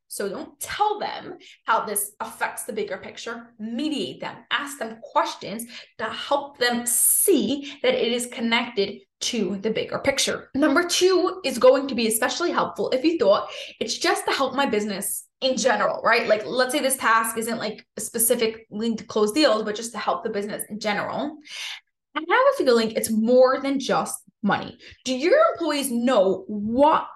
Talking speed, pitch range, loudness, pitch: 185 wpm, 220-290 Hz, -23 LUFS, 245 Hz